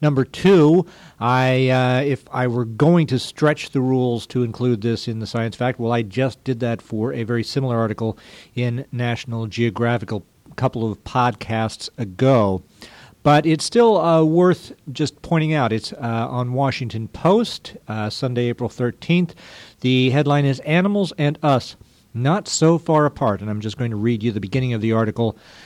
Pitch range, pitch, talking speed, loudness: 115-145 Hz, 125 Hz, 180 wpm, -20 LUFS